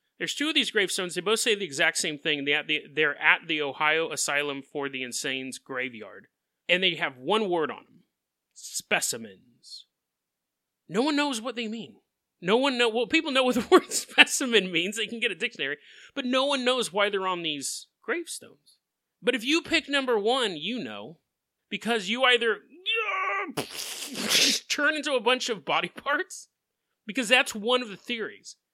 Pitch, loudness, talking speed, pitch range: 230 Hz, -25 LUFS, 180 wpm, 175-275 Hz